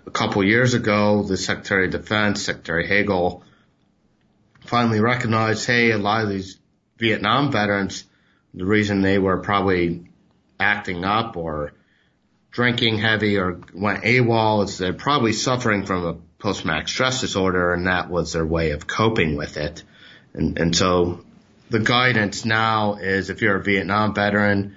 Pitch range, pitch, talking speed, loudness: 90-110 Hz, 100 Hz, 155 wpm, -20 LUFS